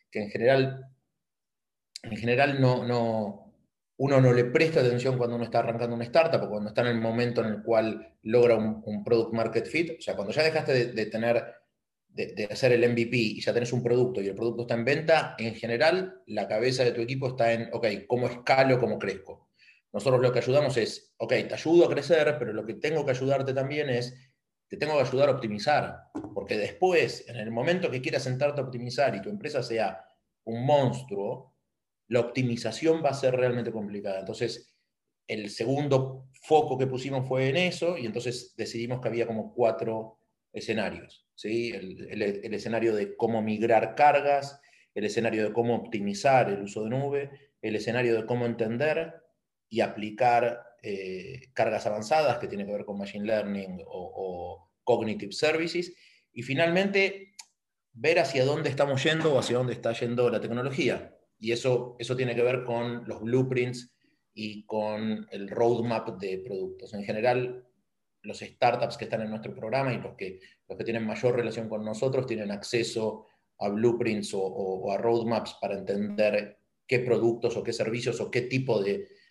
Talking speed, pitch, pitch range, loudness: 185 wpm, 120 Hz, 110-130 Hz, -28 LUFS